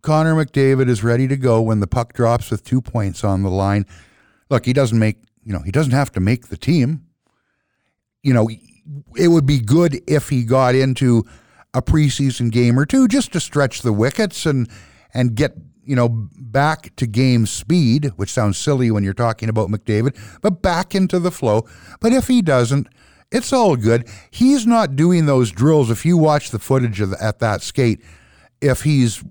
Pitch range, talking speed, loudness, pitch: 110-150 Hz, 195 wpm, -17 LUFS, 125 Hz